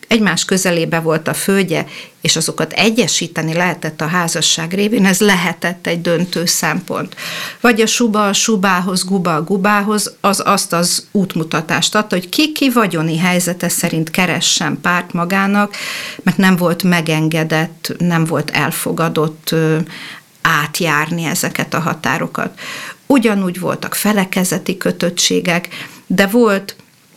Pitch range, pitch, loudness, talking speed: 165-200 Hz, 175 Hz, -15 LUFS, 115 wpm